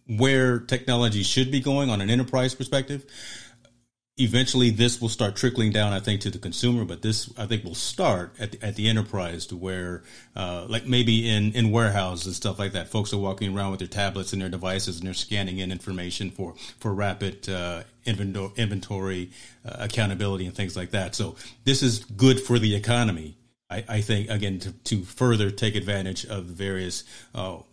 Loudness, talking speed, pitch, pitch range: -26 LUFS, 195 wpm, 105 Hz, 95-120 Hz